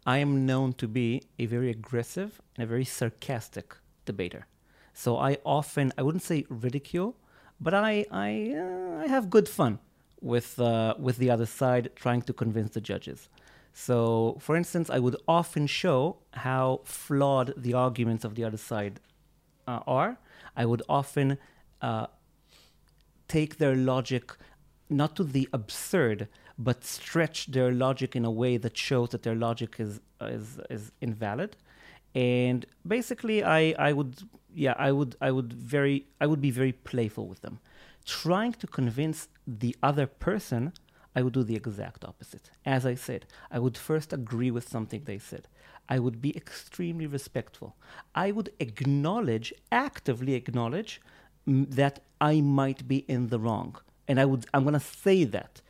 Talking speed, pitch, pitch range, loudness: 160 wpm, 130 Hz, 120-145 Hz, -29 LUFS